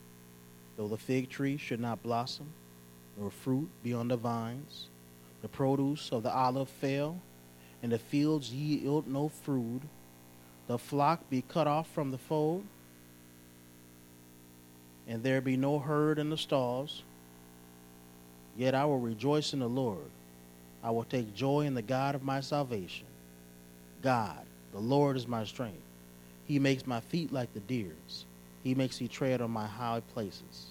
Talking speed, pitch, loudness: 155 wpm, 115 Hz, -34 LUFS